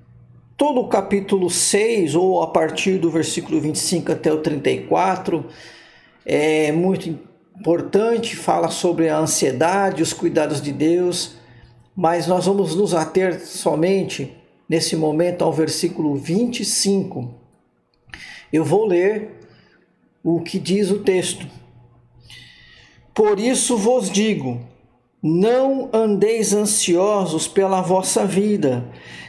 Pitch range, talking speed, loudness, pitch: 155-195 Hz, 110 wpm, -19 LUFS, 175 Hz